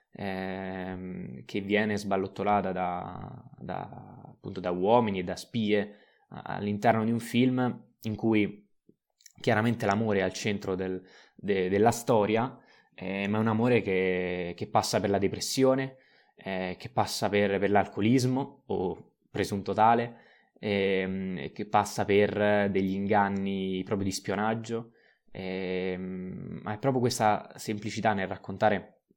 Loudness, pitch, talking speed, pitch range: -29 LUFS, 100 Hz, 130 wpm, 95-110 Hz